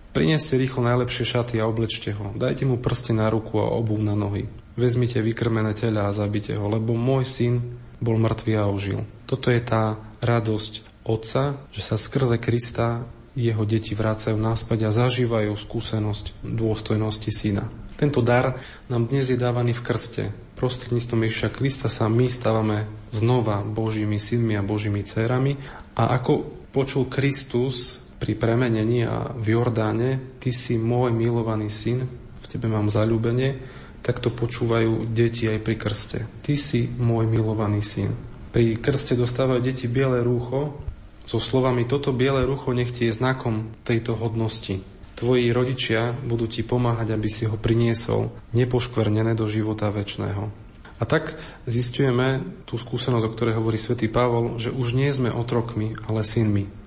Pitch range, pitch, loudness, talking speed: 110-125 Hz, 115 Hz, -24 LUFS, 150 wpm